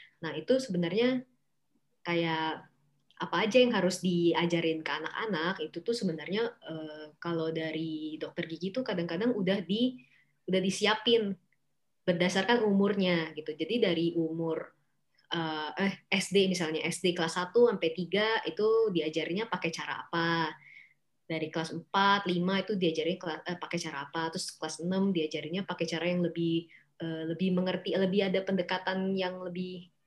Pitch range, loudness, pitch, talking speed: 160-195 Hz, -31 LUFS, 175 Hz, 135 wpm